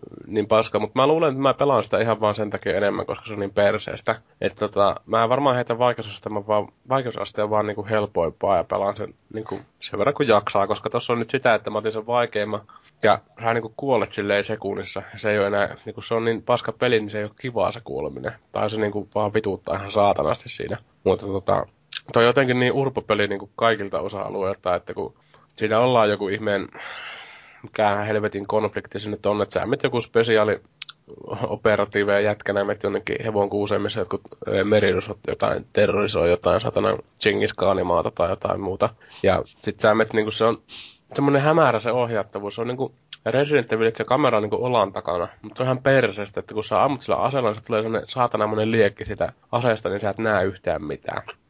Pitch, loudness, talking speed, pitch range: 110 Hz, -23 LUFS, 205 wpm, 105-115 Hz